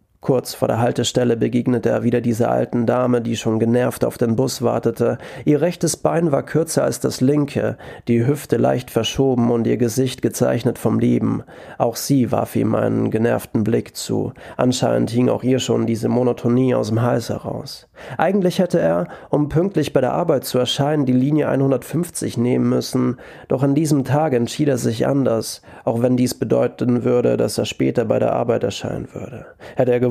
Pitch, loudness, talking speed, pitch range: 125 Hz, -19 LUFS, 185 wpm, 115-140 Hz